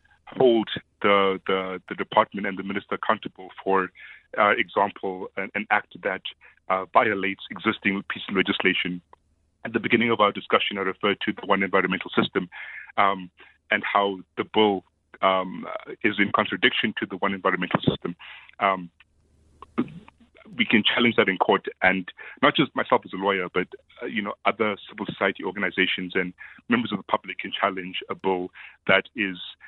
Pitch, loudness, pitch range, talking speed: 95 Hz, -24 LUFS, 95-100 Hz, 165 wpm